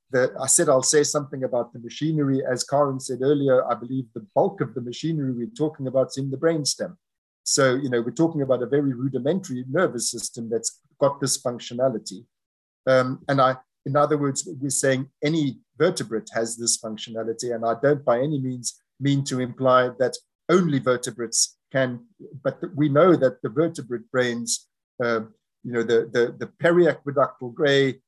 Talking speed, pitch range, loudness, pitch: 180 wpm, 120-145 Hz, -23 LUFS, 130 Hz